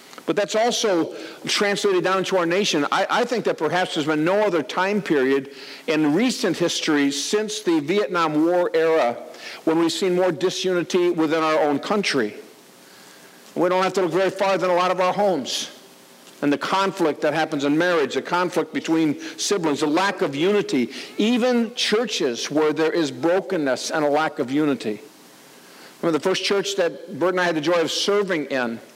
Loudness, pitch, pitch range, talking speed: -21 LUFS, 180 Hz, 155-200 Hz, 185 wpm